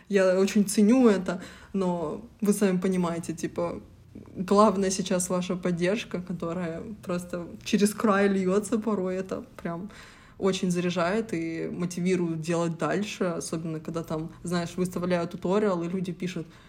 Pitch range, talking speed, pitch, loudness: 170-200 Hz, 130 wpm, 185 Hz, -27 LUFS